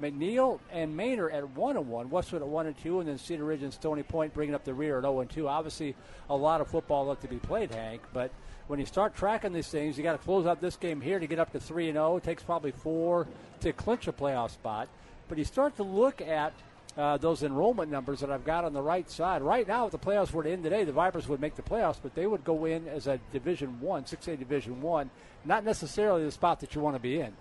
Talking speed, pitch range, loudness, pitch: 250 wpm, 140-175 Hz, -32 LUFS, 155 Hz